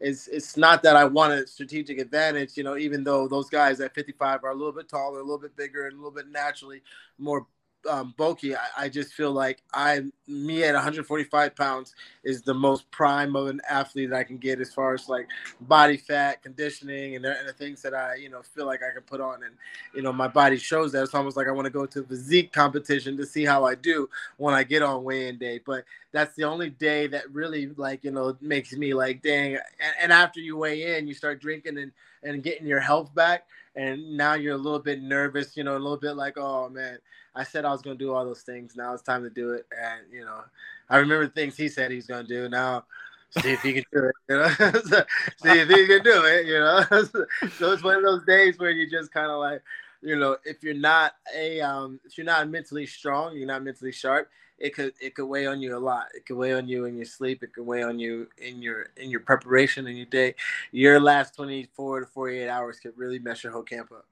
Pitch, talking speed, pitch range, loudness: 140 Hz, 250 wpm, 130-150 Hz, -24 LUFS